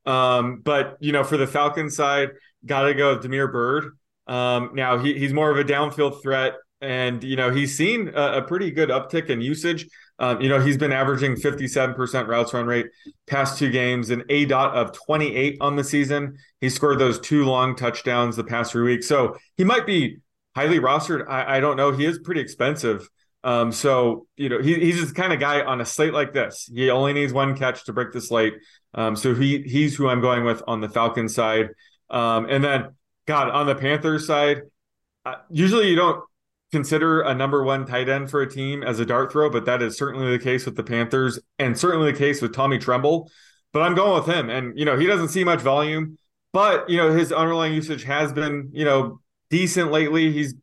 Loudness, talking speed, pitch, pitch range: -22 LUFS, 215 wpm, 140 Hz, 125-150 Hz